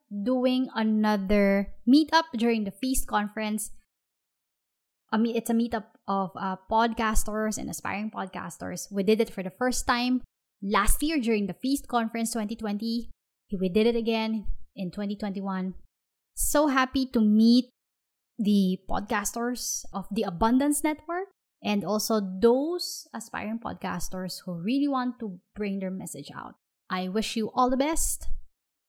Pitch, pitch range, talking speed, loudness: 220 Hz, 205-250 Hz, 140 wpm, -27 LUFS